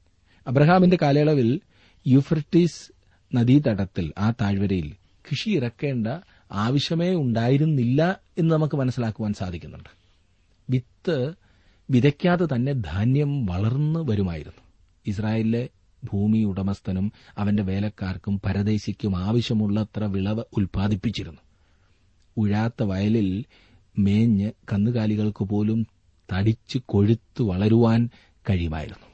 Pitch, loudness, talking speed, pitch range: 105 Hz, -23 LUFS, 75 wpm, 95-125 Hz